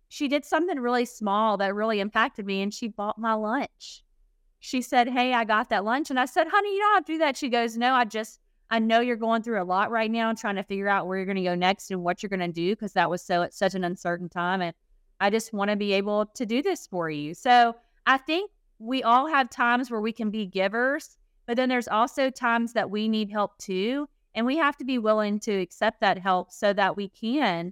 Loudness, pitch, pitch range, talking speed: -26 LUFS, 220 Hz, 195-250 Hz, 260 wpm